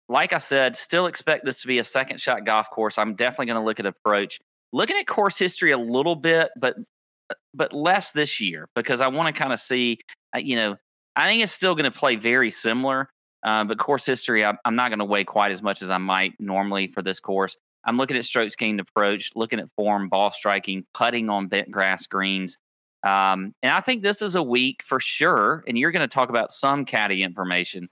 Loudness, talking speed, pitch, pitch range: -22 LUFS, 220 wpm, 115 Hz, 100-135 Hz